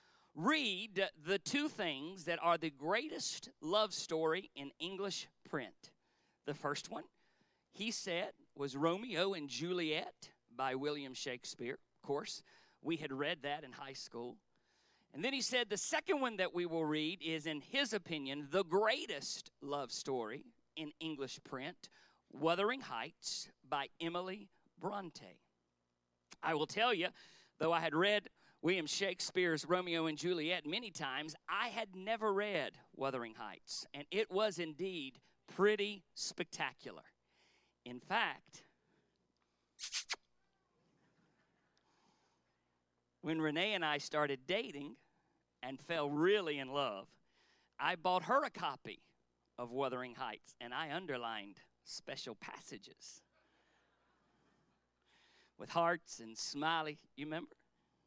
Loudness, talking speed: -39 LUFS, 125 wpm